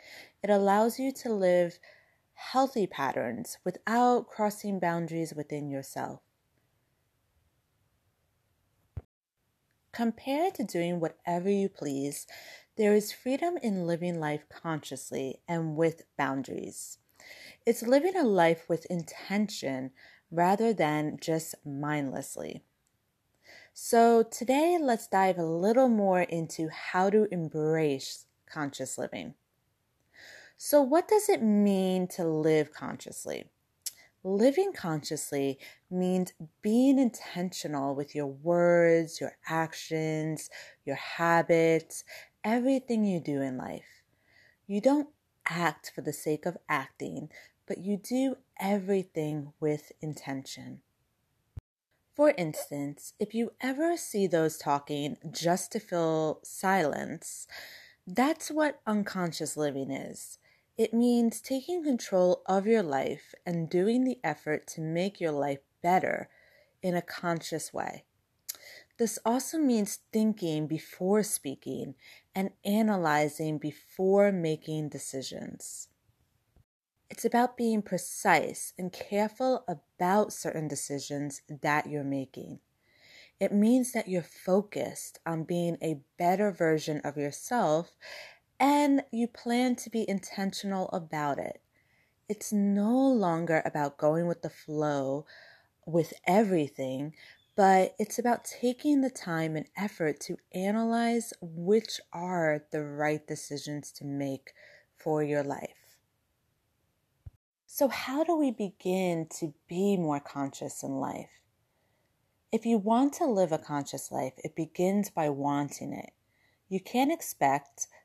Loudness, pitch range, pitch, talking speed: -30 LUFS, 150-215 Hz, 175 Hz, 115 wpm